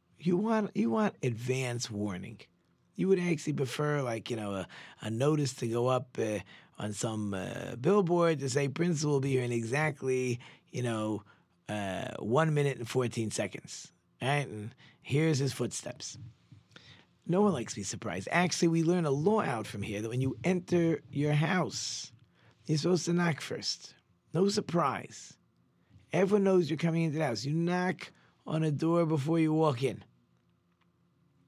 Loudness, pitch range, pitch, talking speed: -31 LUFS, 115-165 Hz, 140 Hz, 170 wpm